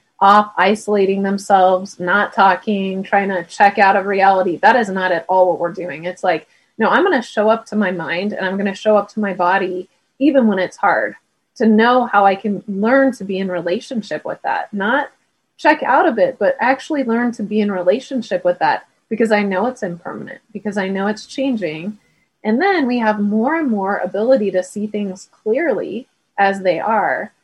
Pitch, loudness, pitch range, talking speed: 200 Hz, -16 LUFS, 185-225 Hz, 205 wpm